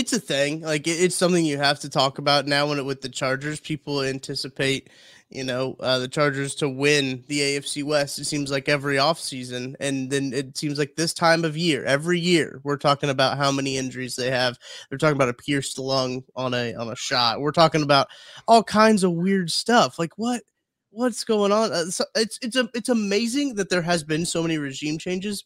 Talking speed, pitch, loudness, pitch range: 215 wpm, 145 Hz, -23 LUFS, 135-175 Hz